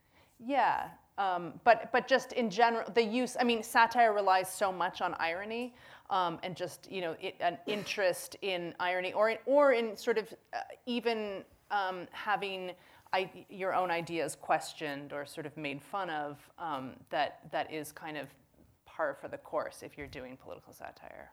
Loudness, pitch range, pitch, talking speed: -33 LUFS, 175-230 Hz, 190 Hz, 175 wpm